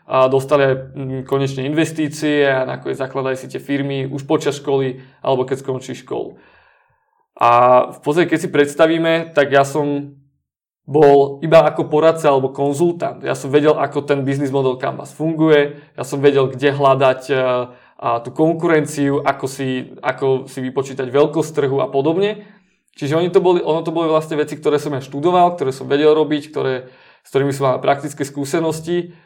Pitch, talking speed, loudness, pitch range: 140 Hz, 170 wpm, -17 LUFS, 135-155 Hz